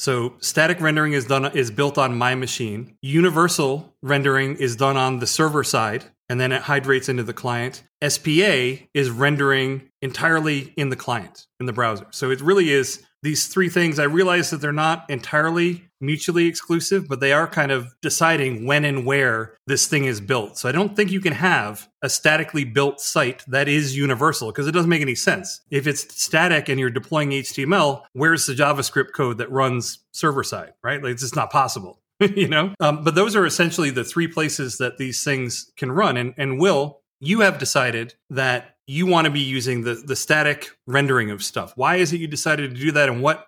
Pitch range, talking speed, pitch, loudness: 130-155 Hz, 205 wpm, 140 Hz, -20 LUFS